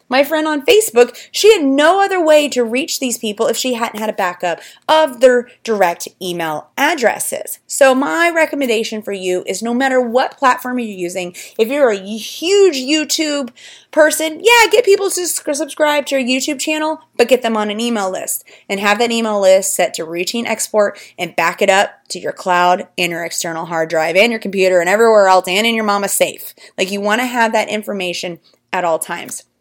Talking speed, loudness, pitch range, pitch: 205 wpm, -15 LUFS, 190-295 Hz, 230 Hz